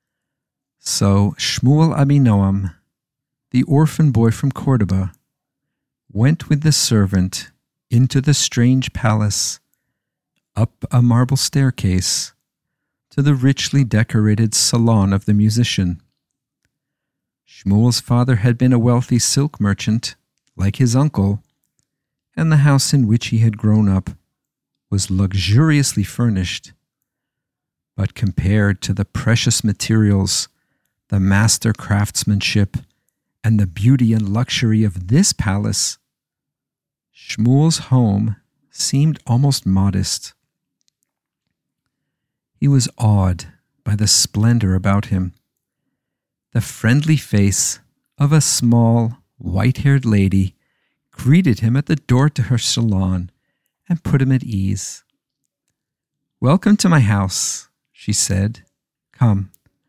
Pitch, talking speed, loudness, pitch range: 120 Hz, 110 wpm, -16 LUFS, 100-140 Hz